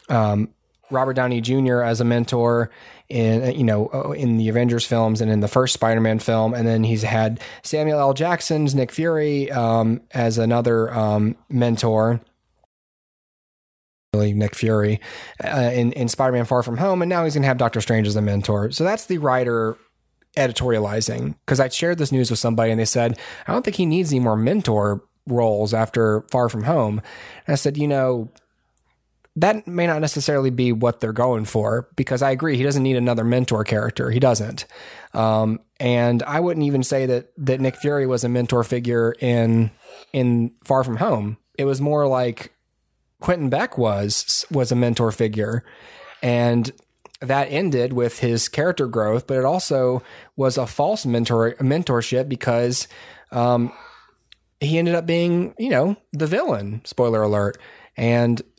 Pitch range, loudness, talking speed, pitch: 115-135 Hz, -21 LUFS, 170 wpm, 120 Hz